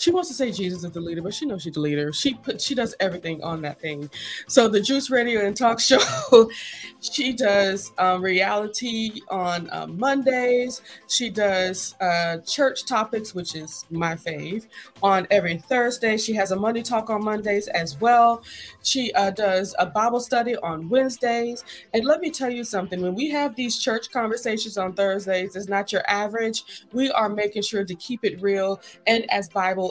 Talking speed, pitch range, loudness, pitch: 190 wpm, 185-240 Hz, -23 LUFS, 210 Hz